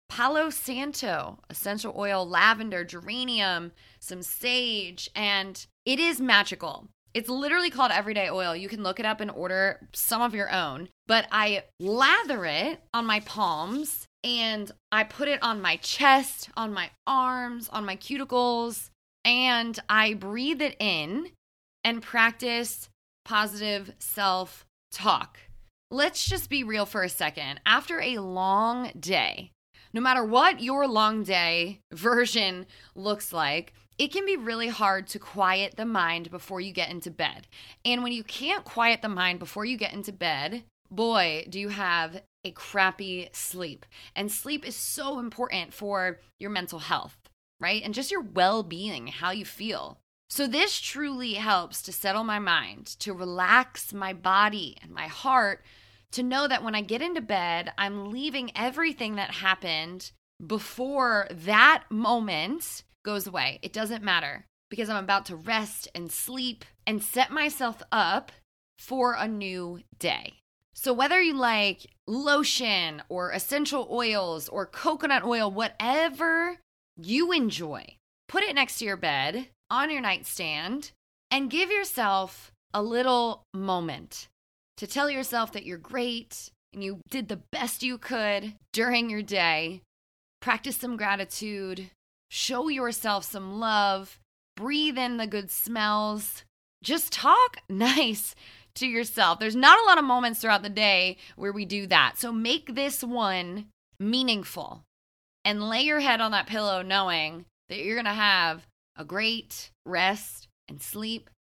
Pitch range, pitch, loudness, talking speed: 190-250 Hz, 215 Hz, -26 LUFS, 150 wpm